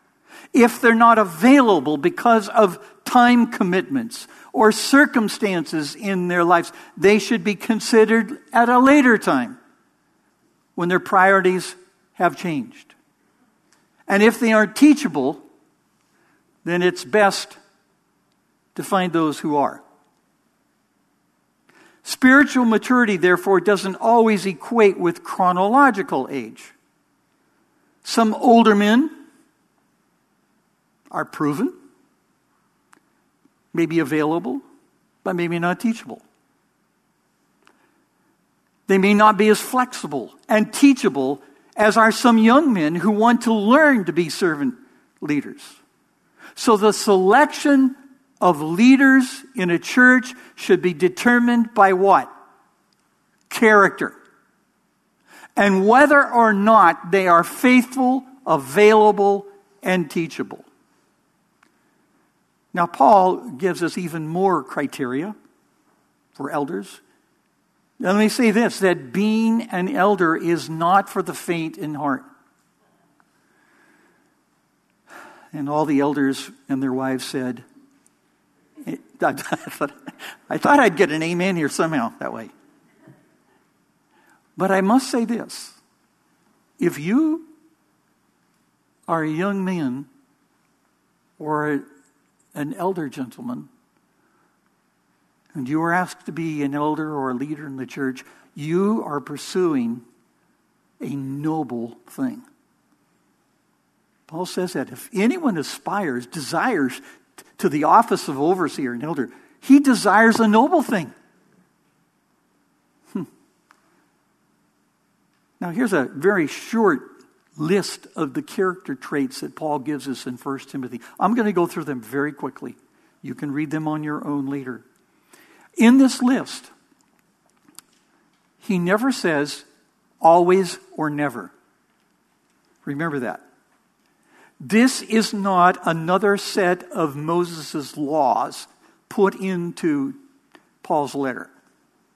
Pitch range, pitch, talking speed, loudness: 165-245 Hz, 200 Hz, 110 wpm, -19 LUFS